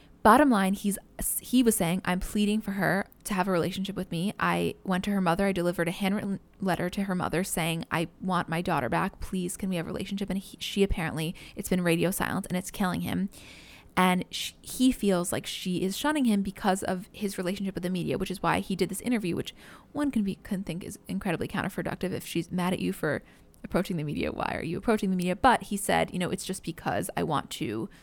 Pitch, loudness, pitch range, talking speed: 185 Hz, -29 LUFS, 175-200 Hz, 240 wpm